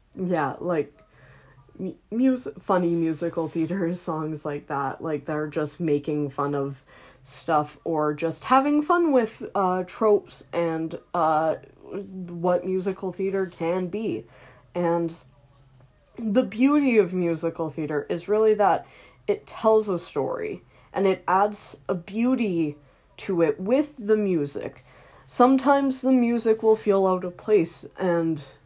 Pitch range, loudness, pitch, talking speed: 155-215 Hz, -24 LUFS, 180 Hz, 130 wpm